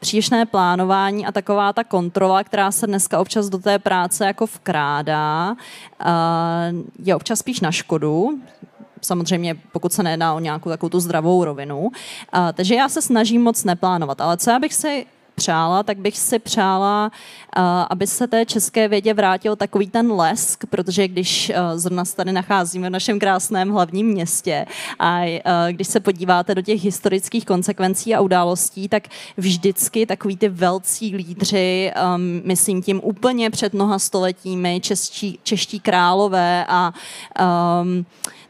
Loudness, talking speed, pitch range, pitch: -19 LUFS, 145 wpm, 180-210 Hz, 190 Hz